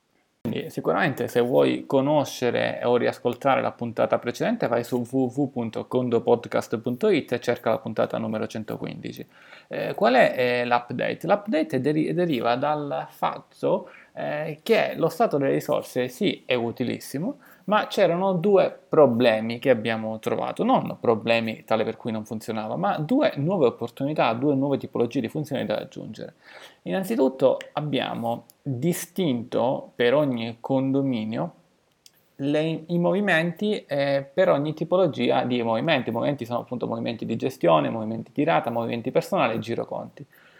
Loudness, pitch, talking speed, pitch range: -24 LUFS, 130 Hz, 135 wpm, 120-165 Hz